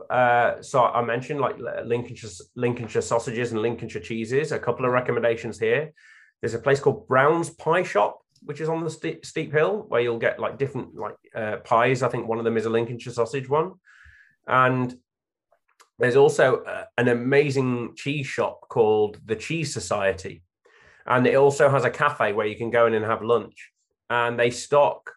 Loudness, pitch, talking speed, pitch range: -23 LUFS, 120 Hz, 180 wpm, 115-140 Hz